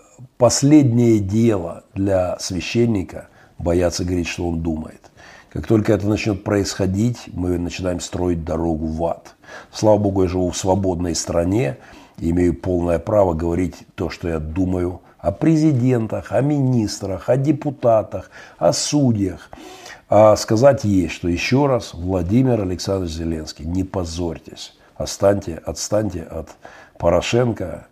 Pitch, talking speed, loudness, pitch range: 95 Hz, 125 wpm, -19 LUFS, 85-110 Hz